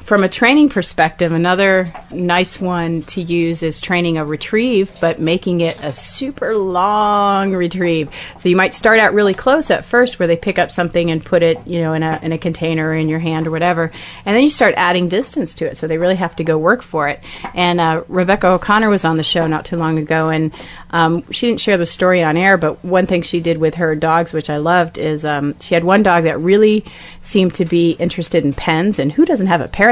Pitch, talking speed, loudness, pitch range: 175 Hz, 235 wpm, -15 LUFS, 160-195 Hz